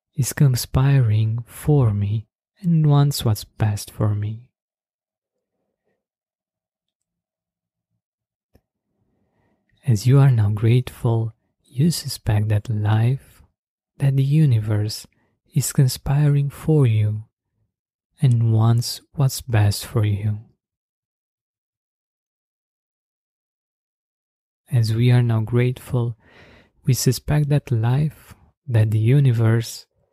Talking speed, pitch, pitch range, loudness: 90 wpm, 115 Hz, 110-135 Hz, -20 LUFS